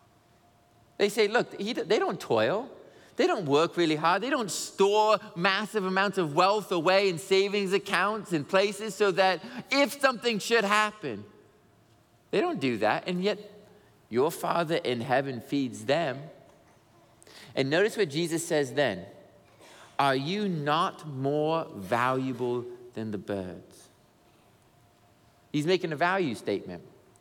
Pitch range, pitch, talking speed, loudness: 130-205 Hz, 175 Hz, 135 wpm, -27 LUFS